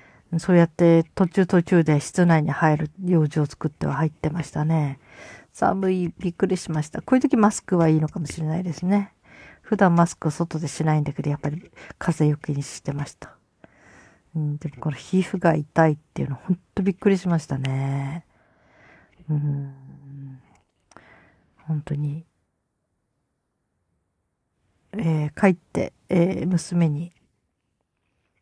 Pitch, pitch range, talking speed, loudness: 160 Hz, 145-175 Hz, 275 characters per minute, -23 LUFS